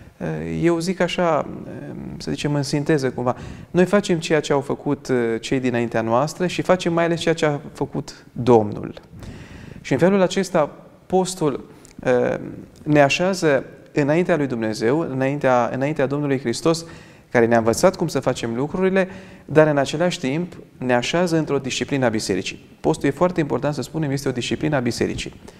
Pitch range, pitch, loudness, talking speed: 125-170 Hz, 145 Hz, -21 LUFS, 160 wpm